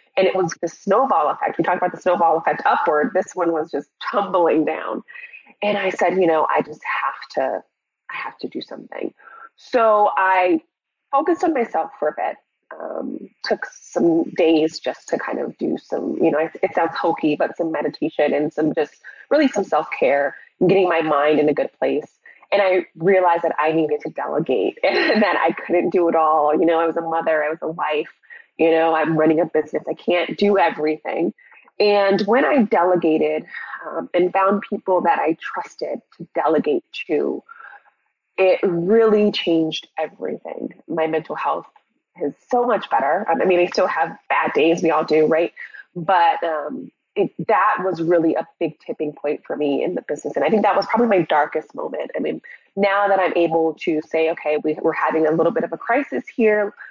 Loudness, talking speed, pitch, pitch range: -20 LUFS, 200 wpm, 170 Hz, 160-205 Hz